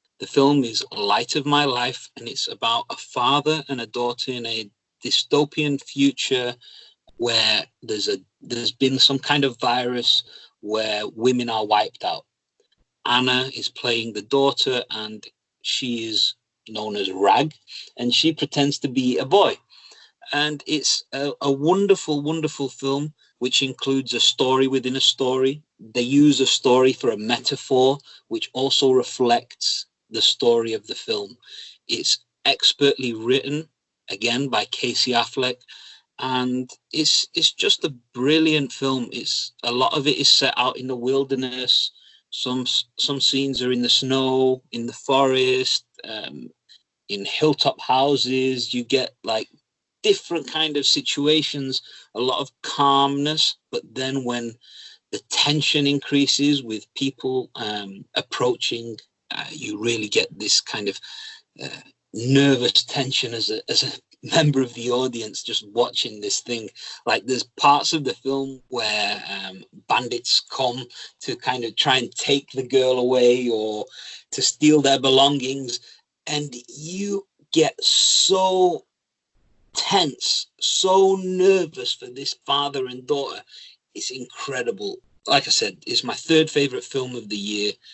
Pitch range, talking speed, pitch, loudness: 125-145 Hz, 145 wpm, 135 Hz, -21 LUFS